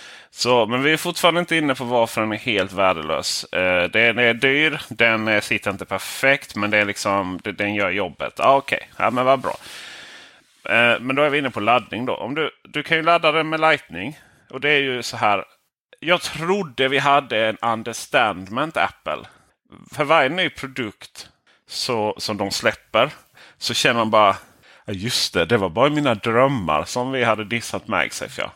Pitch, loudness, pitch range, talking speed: 125 Hz, -20 LUFS, 110-150 Hz, 185 wpm